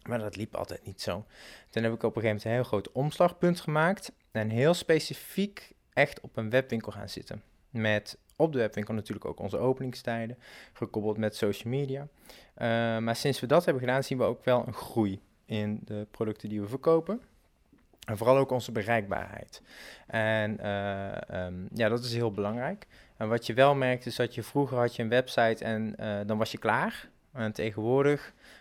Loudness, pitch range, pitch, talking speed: -30 LUFS, 110-130 Hz, 115 Hz, 195 wpm